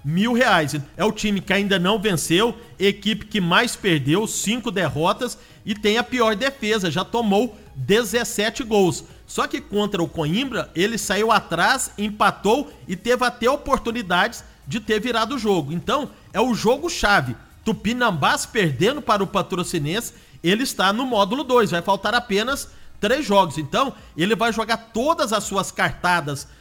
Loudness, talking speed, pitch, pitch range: -21 LUFS, 160 wpm, 210 Hz, 185-235 Hz